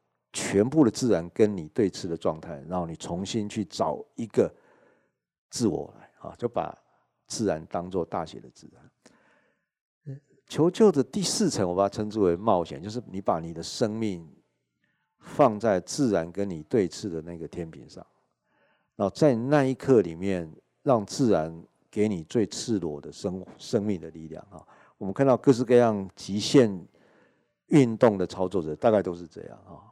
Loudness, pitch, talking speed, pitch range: -26 LUFS, 100 Hz, 240 characters per minute, 85-130 Hz